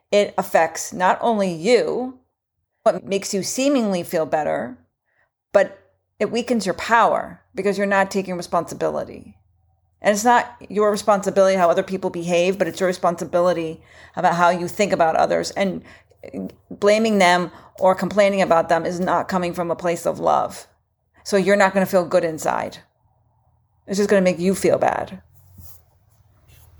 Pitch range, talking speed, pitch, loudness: 165-200 Hz, 160 wpm, 180 Hz, -20 LUFS